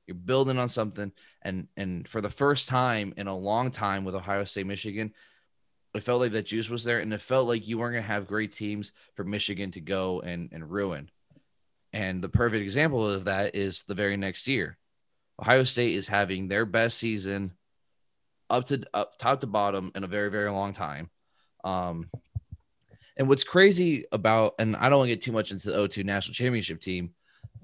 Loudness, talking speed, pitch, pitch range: -28 LUFS, 200 wpm, 105 Hz, 100-115 Hz